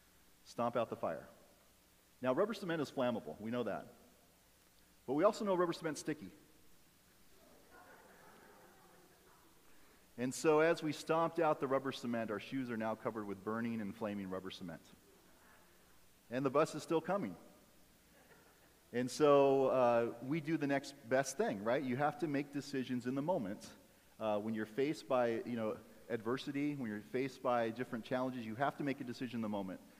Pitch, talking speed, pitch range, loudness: 130 Hz, 170 wpm, 115-145 Hz, -38 LUFS